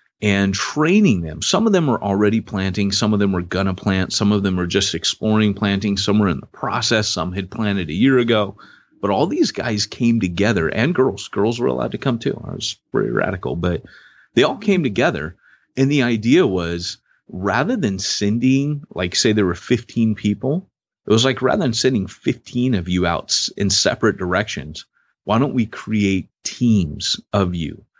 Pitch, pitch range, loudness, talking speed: 105 Hz, 95-120 Hz, -19 LUFS, 190 wpm